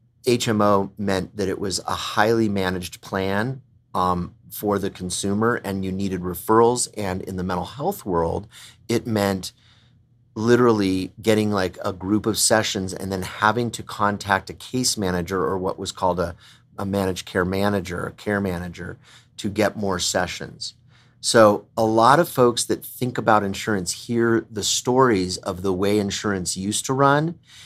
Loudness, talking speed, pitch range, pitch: -22 LUFS, 165 wpm, 95-115 Hz, 100 Hz